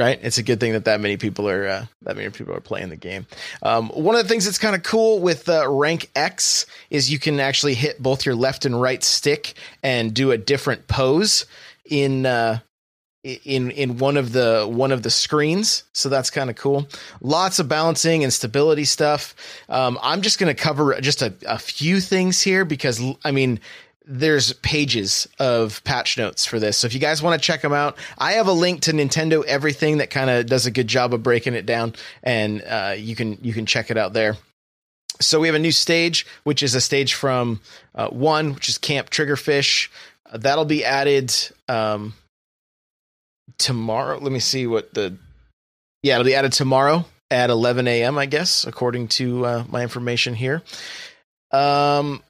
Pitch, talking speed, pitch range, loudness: 135 Hz, 200 wpm, 120-150 Hz, -19 LUFS